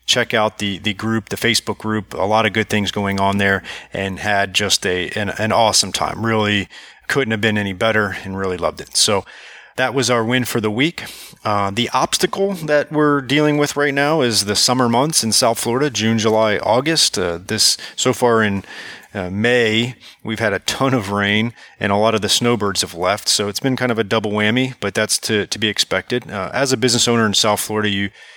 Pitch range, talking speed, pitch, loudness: 100-125 Hz, 220 wpm, 110 Hz, -17 LUFS